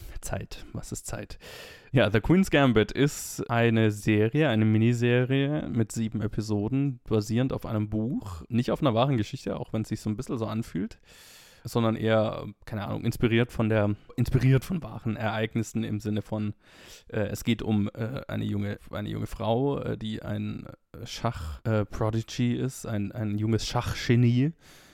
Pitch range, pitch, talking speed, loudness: 105-120 Hz, 110 Hz, 165 wpm, -28 LUFS